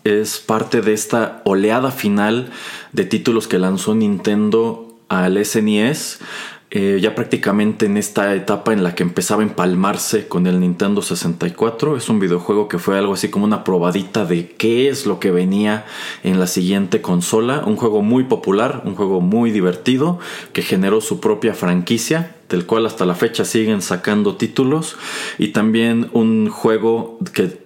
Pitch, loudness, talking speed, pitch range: 105 Hz, -17 LUFS, 165 wpm, 95-115 Hz